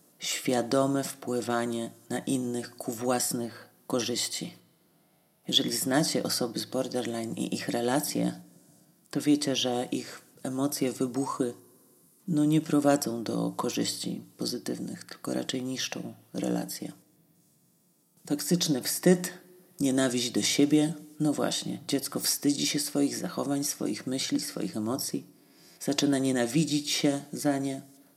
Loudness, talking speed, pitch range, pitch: -29 LUFS, 110 wpm, 125-150 Hz, 135 Hz